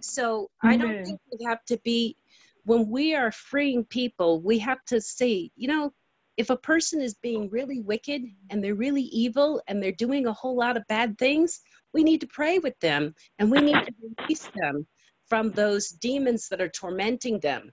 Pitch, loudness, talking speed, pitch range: 235 Hz, -26 LUFS, 195 wpm, 210-260 Hz